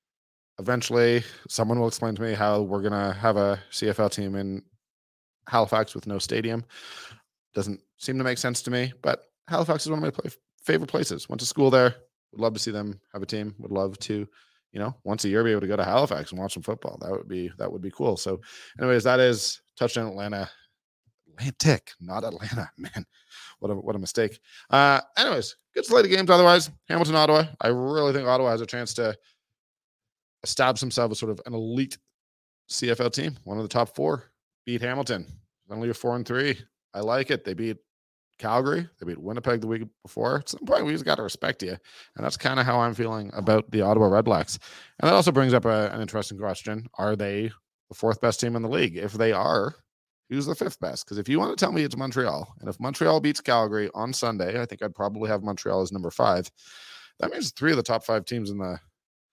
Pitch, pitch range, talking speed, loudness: 115 Hz, 105-125 Hz, 220 wpm, -25 LUFS